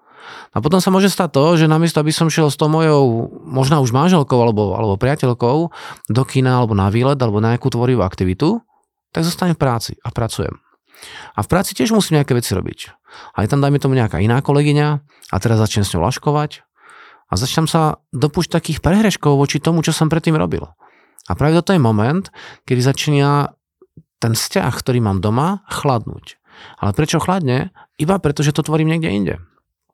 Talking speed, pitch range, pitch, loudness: 185 wpm, 120-165 Hz, 145 Hz, -16 LUFS